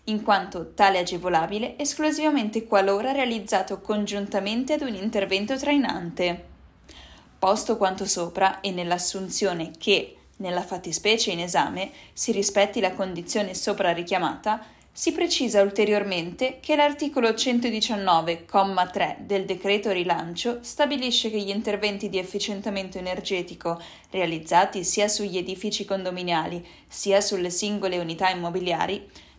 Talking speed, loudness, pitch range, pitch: 110 wpm, -25 LUFS, 180-215 Hz, 200 Hz